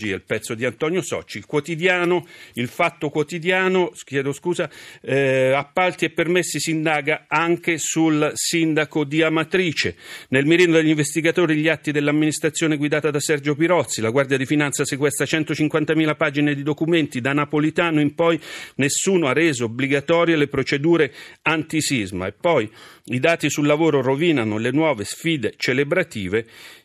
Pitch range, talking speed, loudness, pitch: 140-165 Hz, 145 wpm, -20 LUFS, 155 Hz